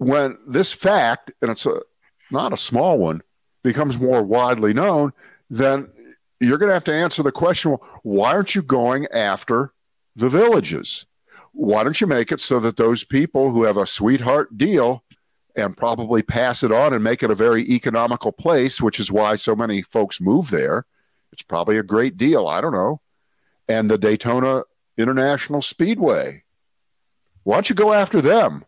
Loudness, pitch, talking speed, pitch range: -19 LUFS, 125 Hz, 175 wpm, 110-145 Hz